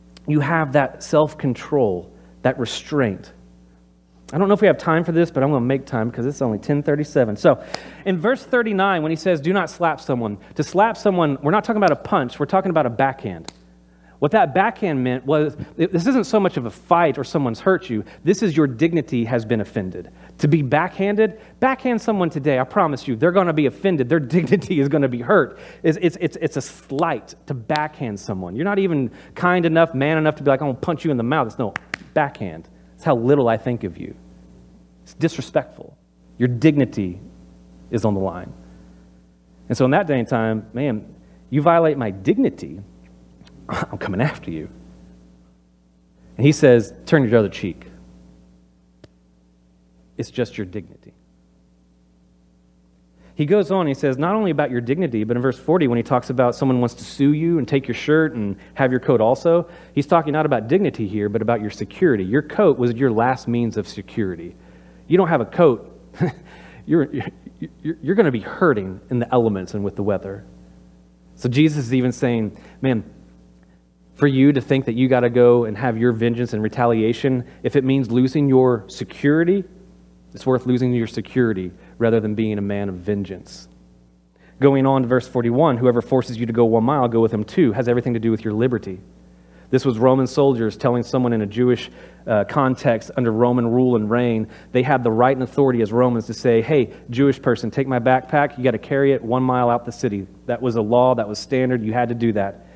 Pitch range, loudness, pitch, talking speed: 95-145 Hz, -19 LUFS, 125 Hz, 205 wpm